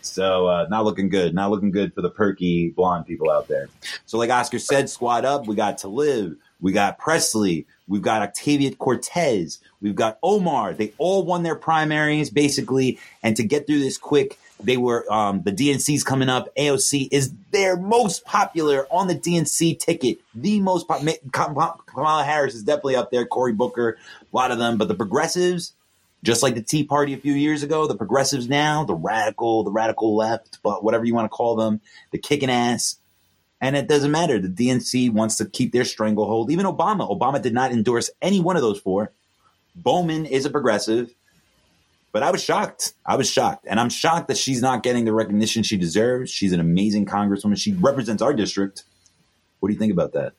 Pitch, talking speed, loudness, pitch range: 125 Hz, 200 wpm, -21 LUFS, 110-150 Hz